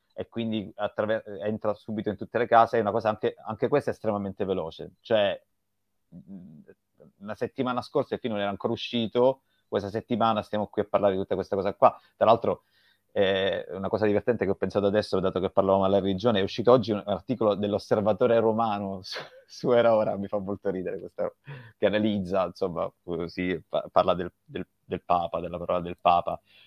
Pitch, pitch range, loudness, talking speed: 105 Hz, 95-115 Hz, -27 LUFS, 185 wpm